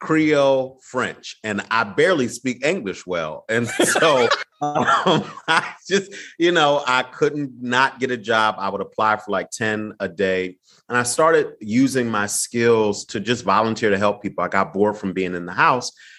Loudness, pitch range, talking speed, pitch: -20 LUFS, 105-135 Hz, 180 wpm, 115 Hz